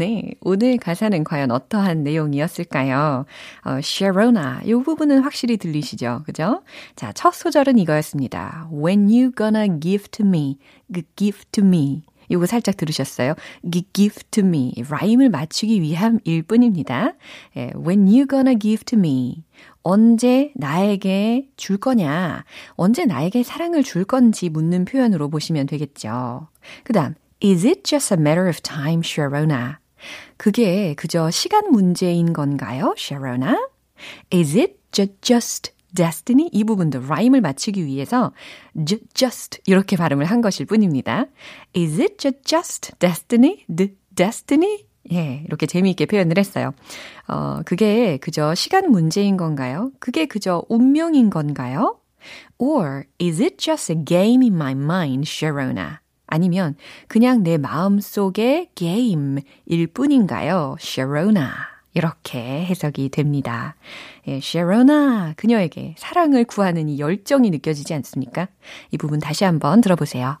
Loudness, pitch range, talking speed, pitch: -19 LUFS, 155-235 Hz, 355 characters per minute, 185 Hz